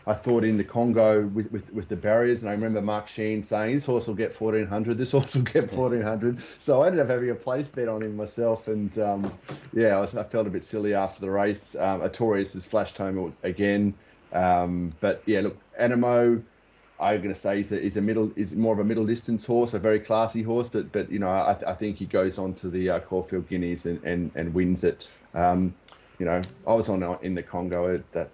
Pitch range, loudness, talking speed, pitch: 95-115 Hz, -26 LUFS, 235 wpm, 105 Hz